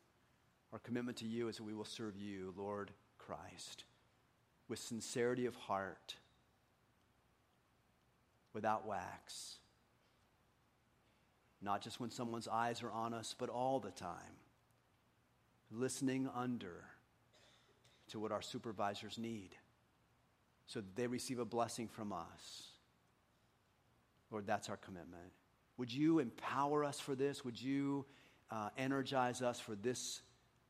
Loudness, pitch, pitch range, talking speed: -44 LUFS, 115 Hz, 105-125 Hz, 125 wpm